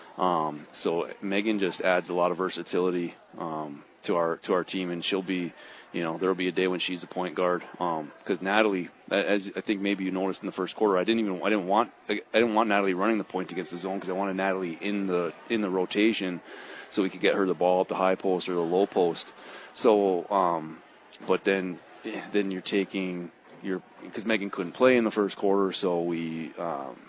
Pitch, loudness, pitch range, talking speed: 95 Hz, -28 LUFS, 90-100 Hz, 225 wpm